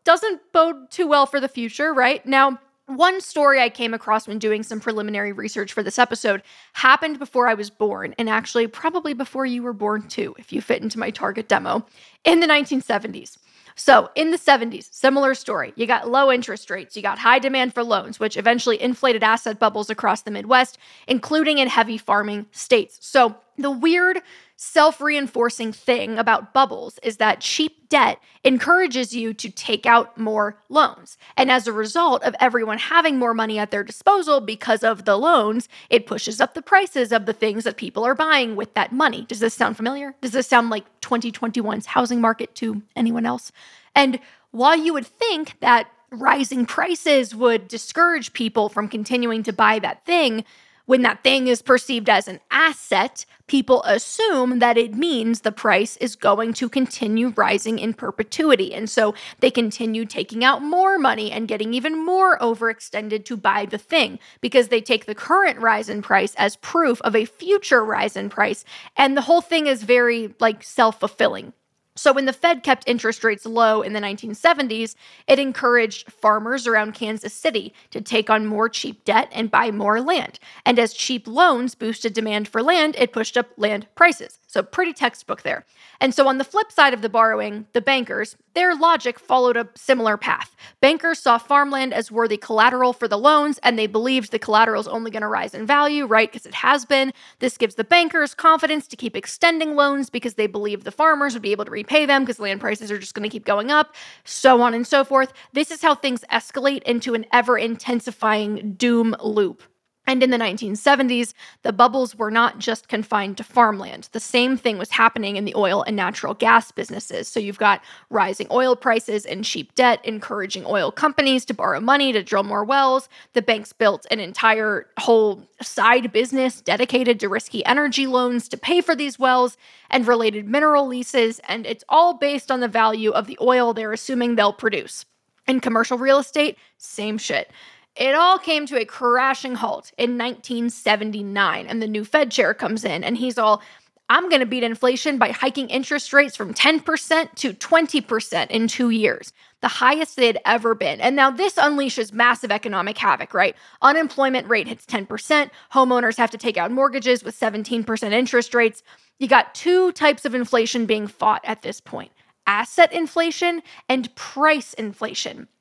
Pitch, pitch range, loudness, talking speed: 240 Hz, 220-275 Hz, -19 LUFS, 185 wpm